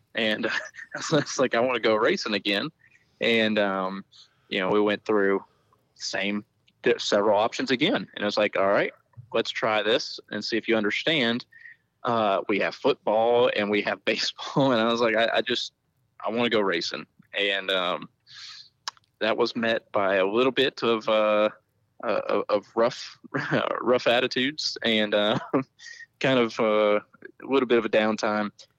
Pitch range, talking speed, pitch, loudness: 105-120 Hz, 170 wpm, 110 Hz, -25 LUFS